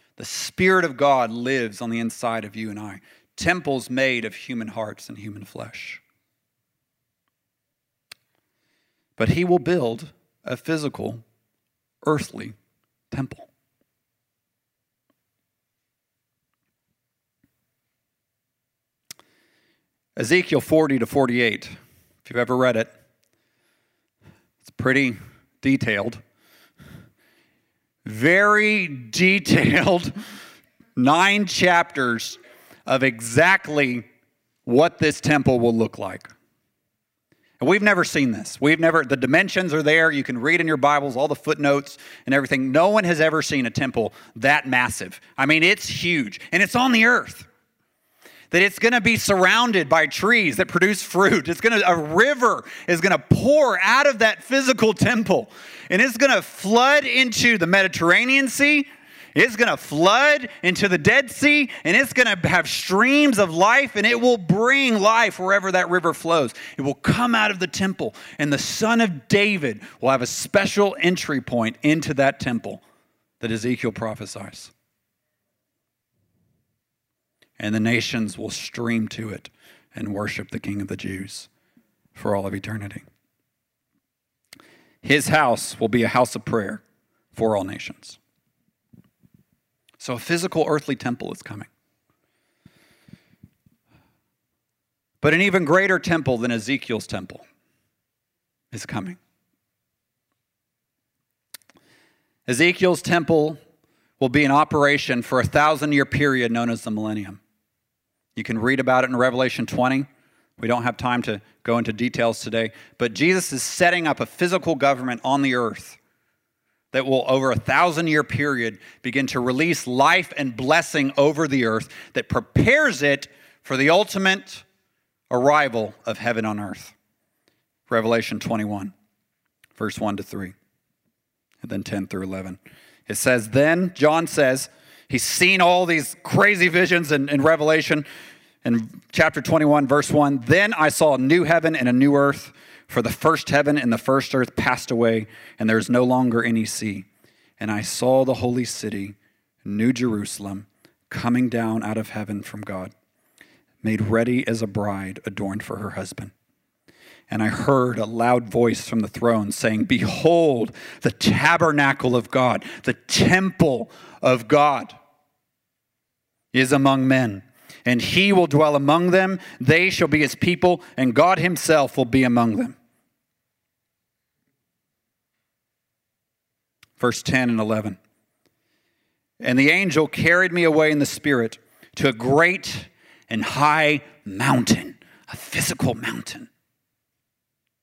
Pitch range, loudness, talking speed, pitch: 115-170 Hz, -20 LUFS, 140 wpm, 135 Hz